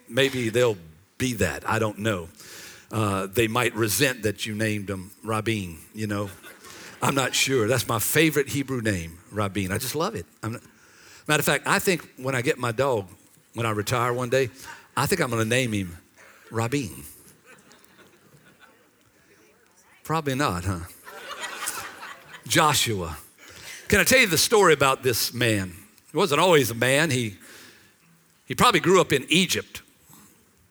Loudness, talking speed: -23 LUFS, 160 wpm